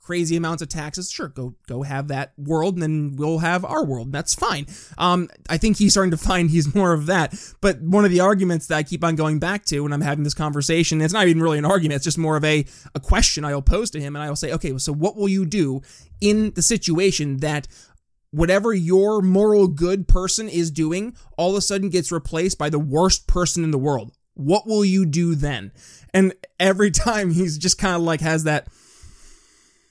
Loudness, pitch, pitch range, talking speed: -20 LUFS, 165 Hz, 150-190 Hz, 225 wpm